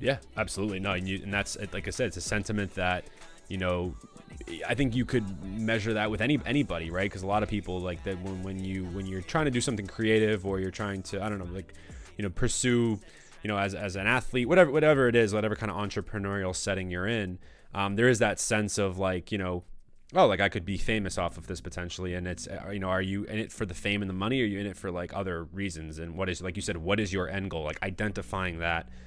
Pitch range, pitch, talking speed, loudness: 90-110 Hz, 100 Hz, 260 wpm, -30 LUFS